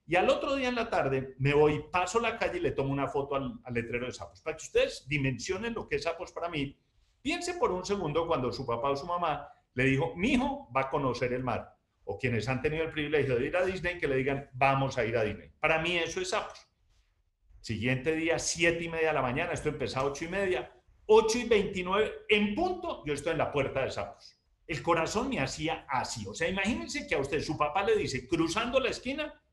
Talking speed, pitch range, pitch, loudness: 240 wpm, 135-195 Hz, 160 Hz, -30 LUFS